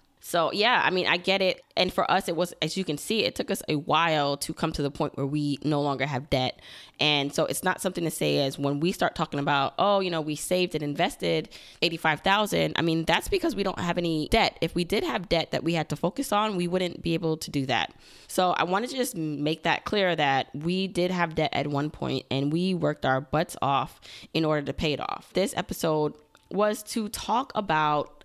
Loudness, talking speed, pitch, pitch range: -26 LUFS, 245 wpm, 160 Hz, 145-185 Hz